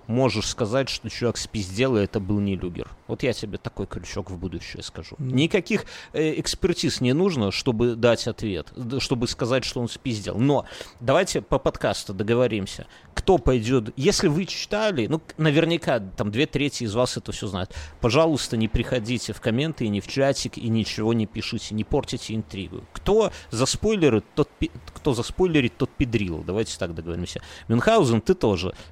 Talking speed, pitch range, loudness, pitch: 170 wpm, 105-135 Hz, -24 LUFS, 115 Hz